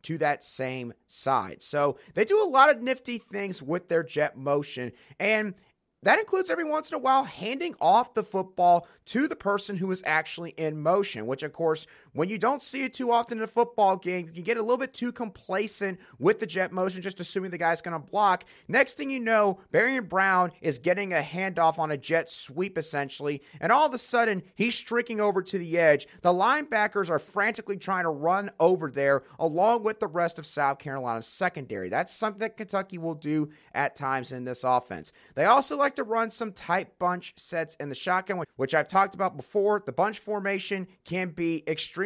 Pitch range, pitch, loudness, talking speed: 160-220 Hz, 185 Hz, -27 LUFS, 210 wpm